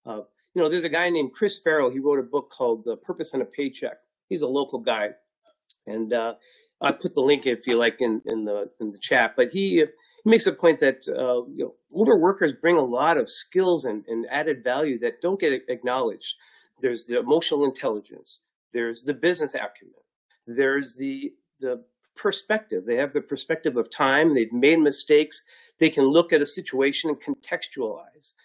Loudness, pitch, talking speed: -24 LUFS, 150 Hz, 195 wpm